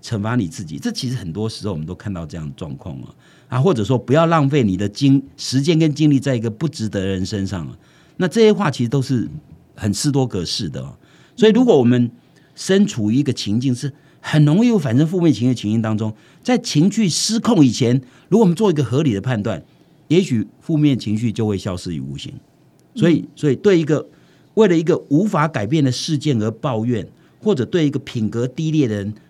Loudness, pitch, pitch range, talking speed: -18 LUFS, 135 Hz, 110-165 Hz, 330 characters per minute